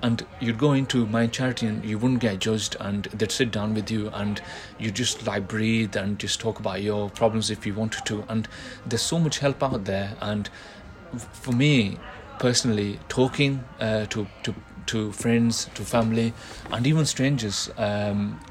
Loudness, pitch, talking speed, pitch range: -25 LUFS, 110 Hz, 180 wpm, 105-120 Hz